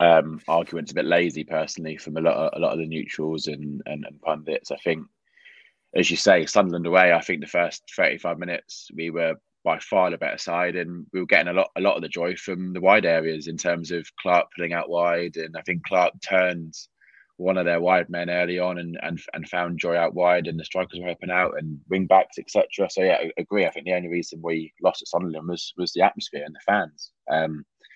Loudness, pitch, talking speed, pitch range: -24 LUFS, 85 Hz, 240 wpm, 80-90 Hz